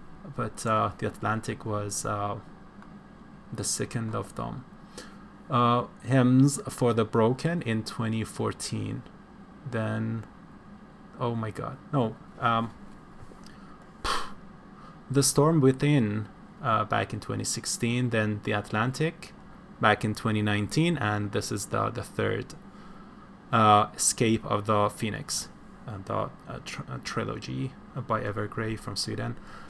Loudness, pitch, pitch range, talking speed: -28 LUFS, 115 Hz, 105-135 Hz, 115 wpm